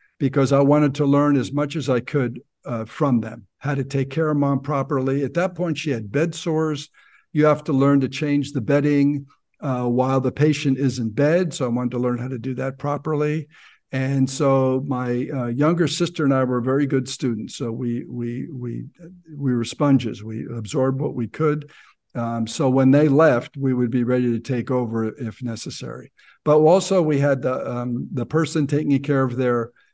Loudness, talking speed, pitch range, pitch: -21 LUFS, 205 wpm, 125-145 Hz, 135 Hz